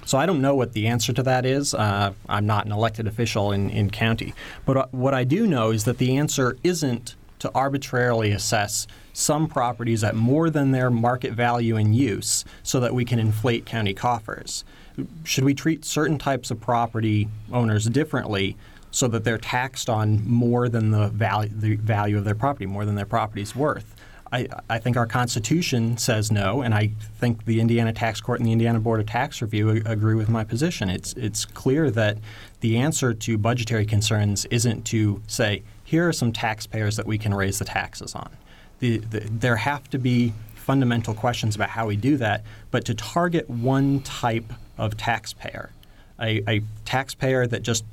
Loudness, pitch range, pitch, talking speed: -23 LUFS, 110-125 Hz, 115 Hz, 185 wpm